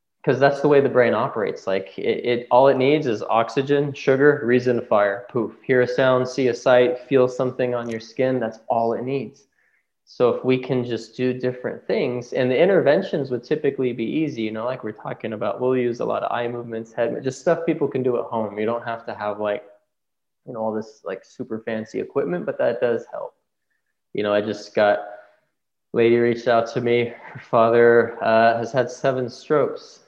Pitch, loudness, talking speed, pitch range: 120 Hz, -21 LUFS, 210 wpm, 115-130 Hz